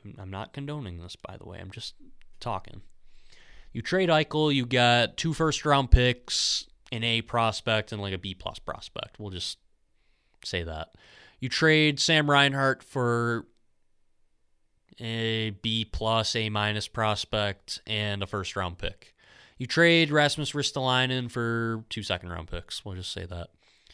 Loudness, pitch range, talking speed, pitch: -26 LUFS, 95-130 Hz, 145 wpm, 110 Hz